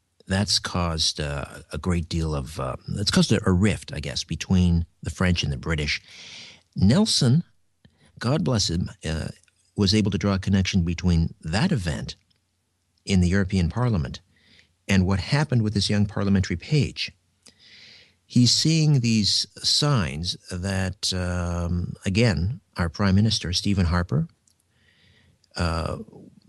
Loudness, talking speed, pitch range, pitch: -23 LUFS, 135 wpm, 85-110 Hz, 95 Hz